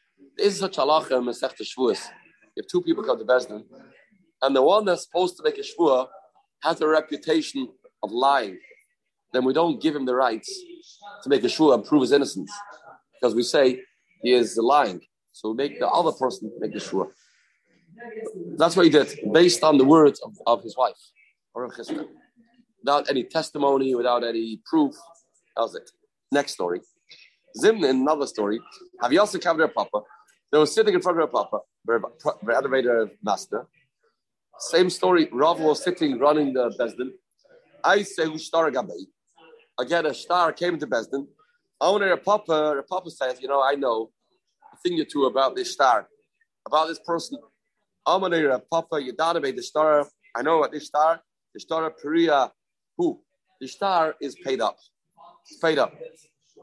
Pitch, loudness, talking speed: 170 Hz, -23 LUFS, 165 wpm